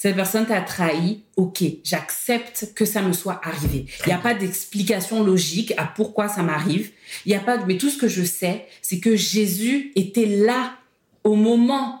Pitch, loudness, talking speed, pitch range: 205 Hz, -21 LUFS, 190 wpm, 180-225 Hz